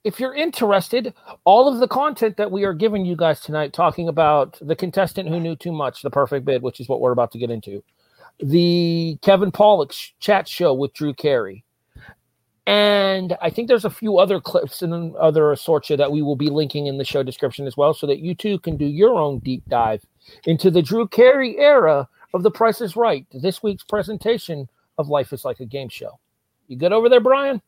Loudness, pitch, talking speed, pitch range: -19 LUFS, 170 Hz, 215 wpm, 140-210 Hz